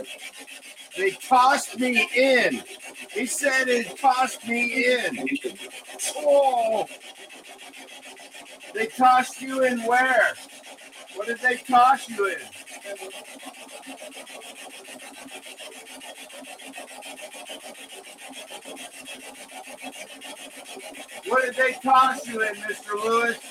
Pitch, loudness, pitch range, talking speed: 255 Hz, -22 LUFS, 235-265 Hz, 75 wpm